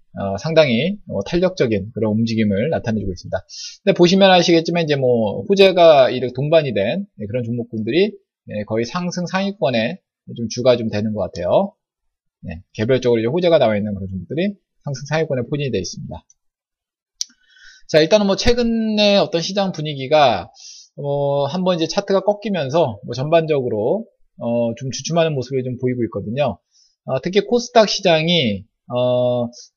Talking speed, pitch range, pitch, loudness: 345 characters per minute, 115-185 Hz, 145 Hz, -18 LUFS